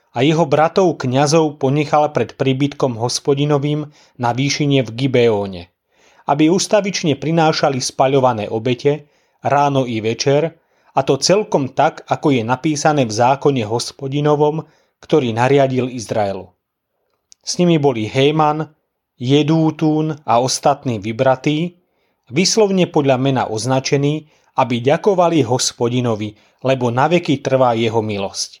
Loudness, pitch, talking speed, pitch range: -16 LUFS, 140 Hz, 110 wpm, 125-155 Hz